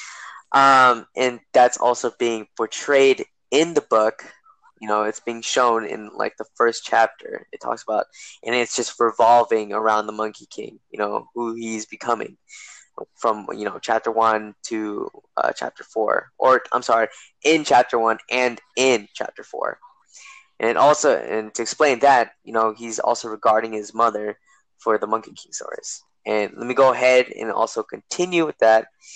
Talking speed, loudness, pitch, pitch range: 170 wpm, -20 LUFS, 115 Hz, 110-125 Hz